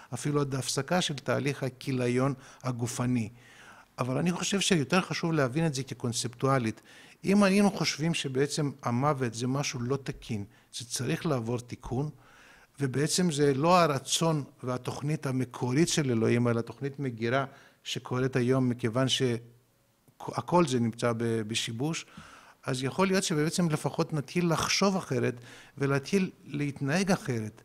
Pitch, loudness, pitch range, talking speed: 135 Hz, -29 LUFS, 125-155 Hz, 125 wpm